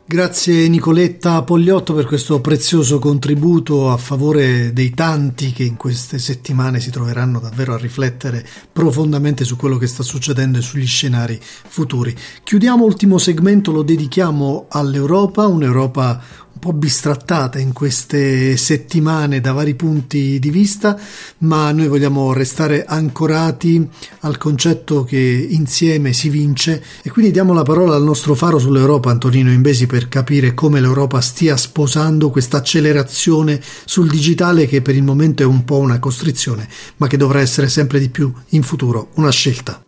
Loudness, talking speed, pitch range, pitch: -14 LUFS, 150 wpm, 130-160 Hz, 145 Hz